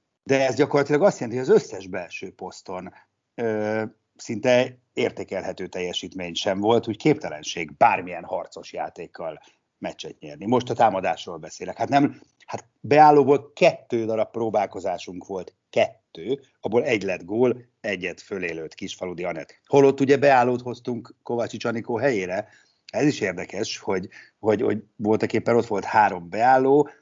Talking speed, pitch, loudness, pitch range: 140 wpm, 120 Hz, -23 LUFS, 110-140 Hz